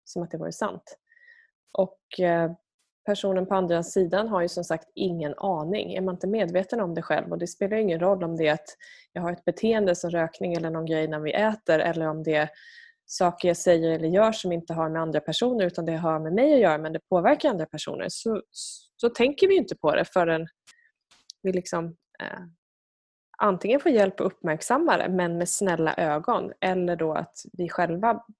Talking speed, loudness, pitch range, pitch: 210 wpm, -25 LUFS, 165-210 Hz, 180 Hz